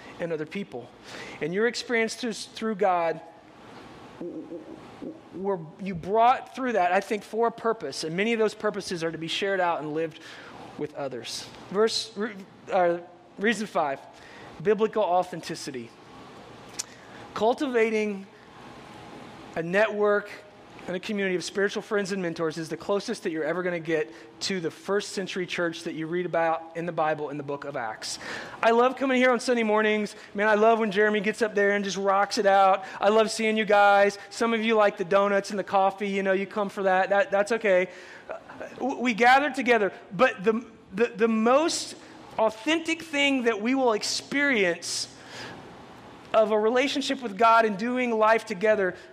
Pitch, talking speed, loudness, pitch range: 205 Hz, 170 wpm, -25 LUFS, 180-225 Hz